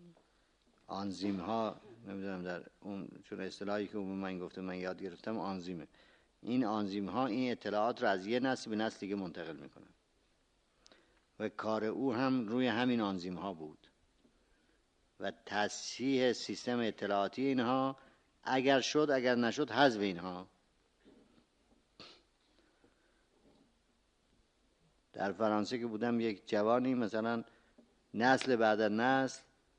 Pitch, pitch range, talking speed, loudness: 110 Hz, 100-125 Hz, 120 wpm, -35 LUFS